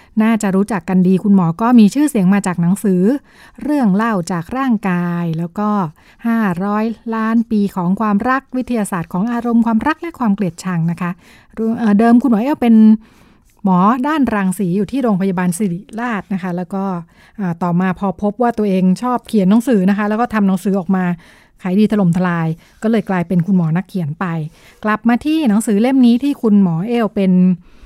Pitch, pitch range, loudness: 205 Hz, 185-230 Hz, -15 LUFS